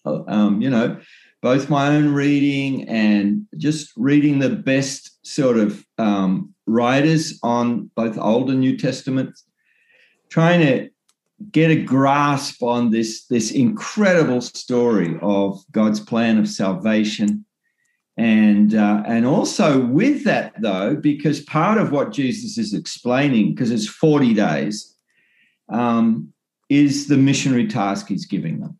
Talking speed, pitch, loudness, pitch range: 130 wpm, 140 Hz, -19 LUFS, 115-160 Hz